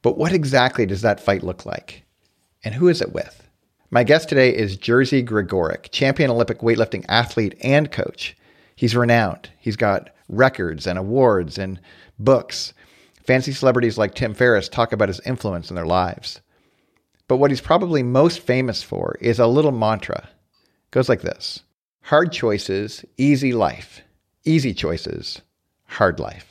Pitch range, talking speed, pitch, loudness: 100-135 Hz, 155 wpm, 115 Hz, -19 LUFS